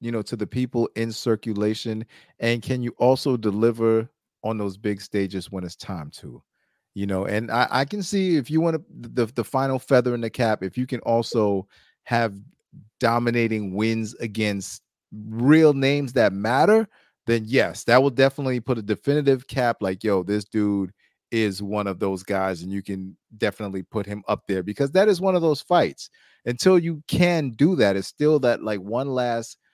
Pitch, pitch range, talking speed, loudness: 115 Hz, 105-135 Hz, 190 wpm, -23 LUFS